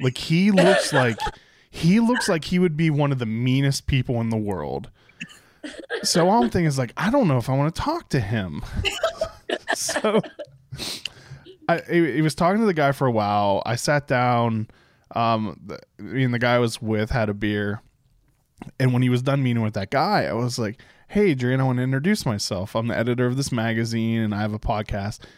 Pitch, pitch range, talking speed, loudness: 130 Hz, 115-165 Hz, 210 wpm, -22 LUFS